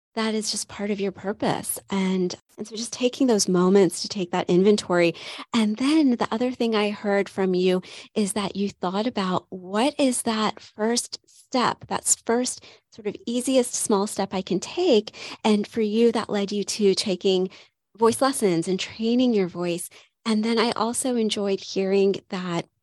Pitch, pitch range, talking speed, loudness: 210 Hz, 190-230 Hz, 180 wpm, -24 LUFS